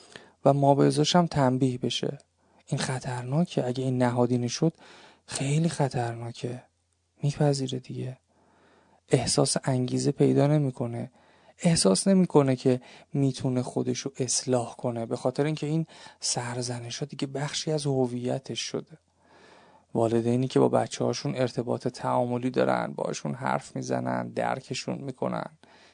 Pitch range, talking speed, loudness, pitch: 125-145 Hz, 120 wpm, -27 LUFS, 130 Hz